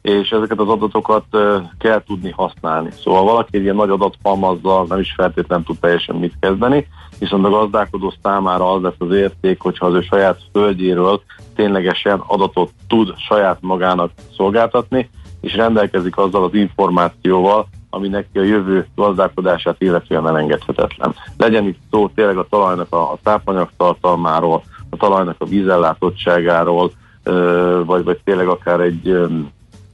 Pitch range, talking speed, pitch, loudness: 90-105 Hz, 140 wpm, 95 Hz, -16 LUFS